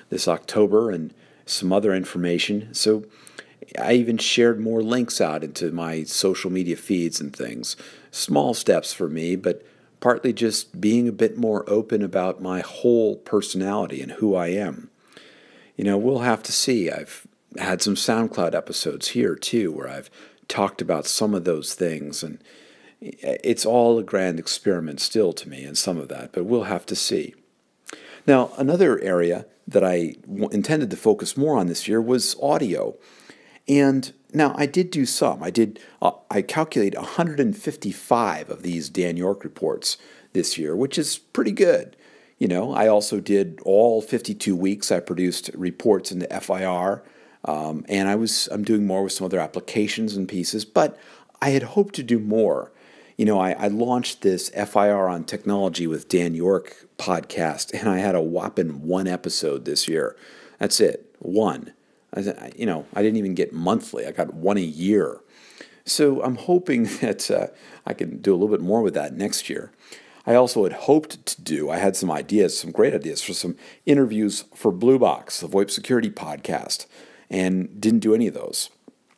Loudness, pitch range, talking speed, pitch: -22 LUFS, 90-120 Hz, 175 wpm, 105 Hz